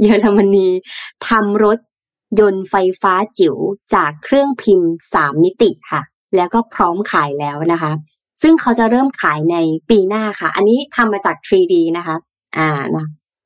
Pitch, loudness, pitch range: 195 Hz, -15 LUFS, 165-230 Hz